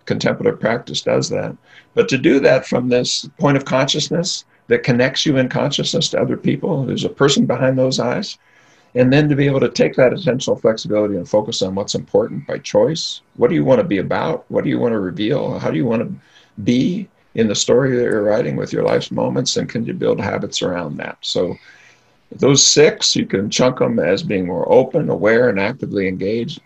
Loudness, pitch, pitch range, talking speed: -17 LUFS, 130 Hz, 120-145 Hz, 215 wpm